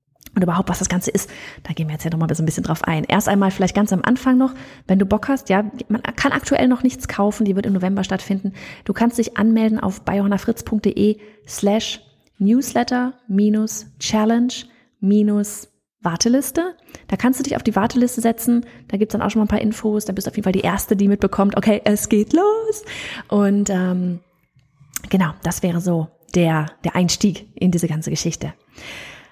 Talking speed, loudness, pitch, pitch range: 200 wpm, -19 LUFS, 205 Hz, 185-230 Hz